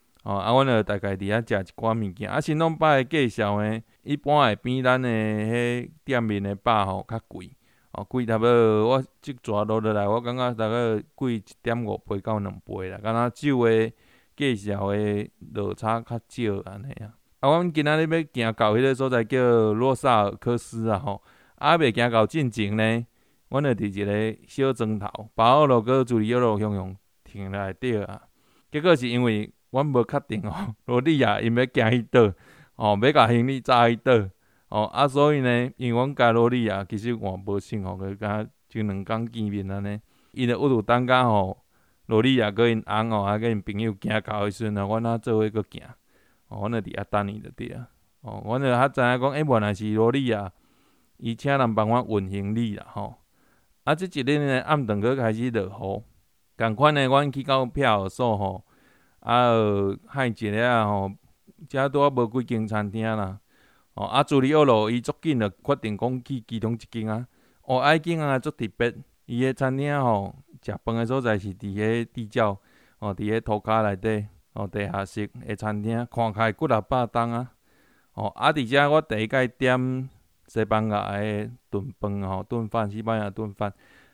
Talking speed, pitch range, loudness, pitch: 265 characters per minute, 105-125 Hz, -24 LUFS, 115 Hz